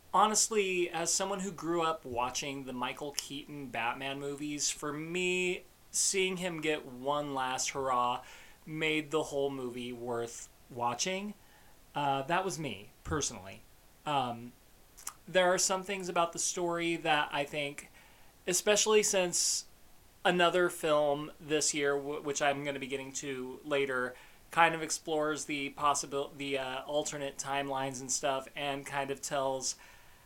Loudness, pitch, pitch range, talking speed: -32 LUFS, 145 Hz, 135-170 Hz, 145 wpm